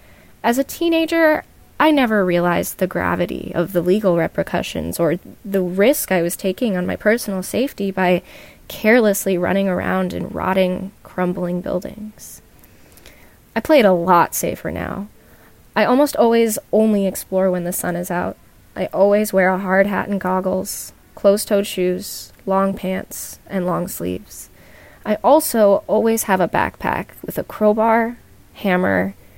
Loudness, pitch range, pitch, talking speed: -18 LUFS, 180-215 Hz, 195 Hz, 150 wpm